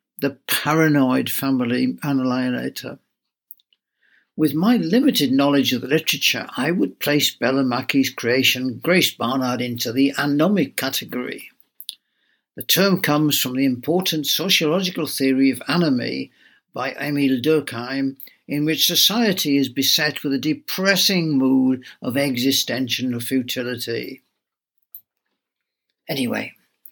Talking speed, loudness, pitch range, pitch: 105 wpm, -19 LUFS, 130-155 Hz, 140 Hz